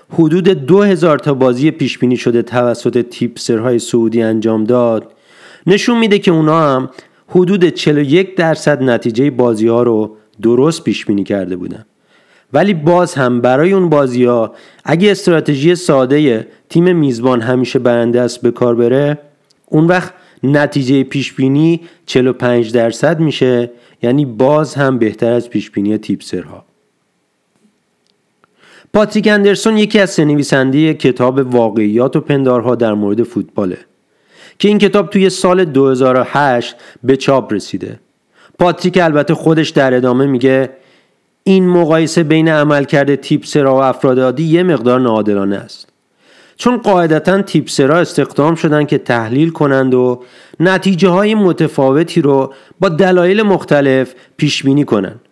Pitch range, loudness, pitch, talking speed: 125-170 Hz, -12 LUFS, 140 Hz, 135 wpm